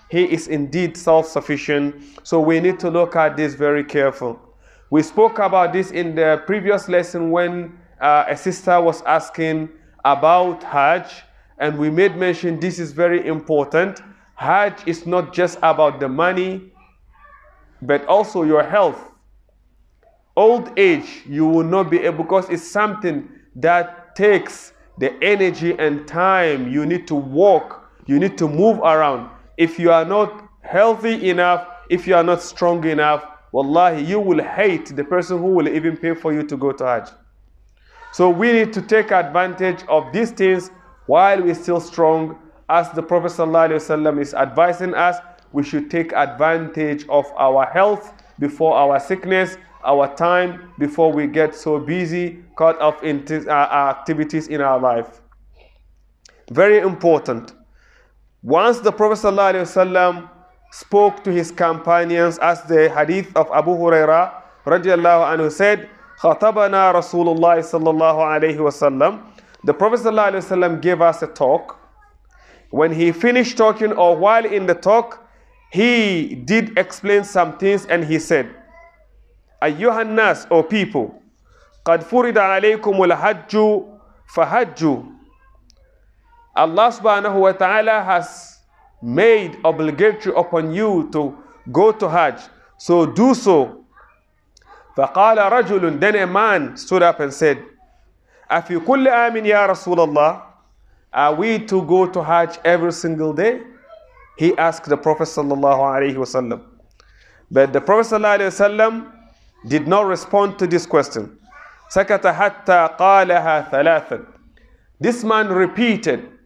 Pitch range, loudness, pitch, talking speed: 155-200 Hz, -17 LUFS, 175 Hz, 130 wpm